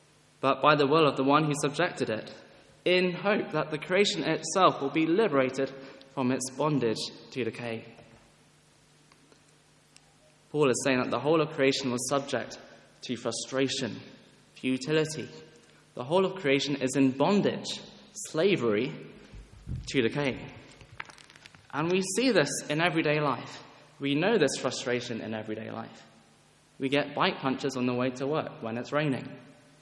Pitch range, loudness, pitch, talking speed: 125-155 Hz, -28 LUFS, 140 Hz, 145 wpm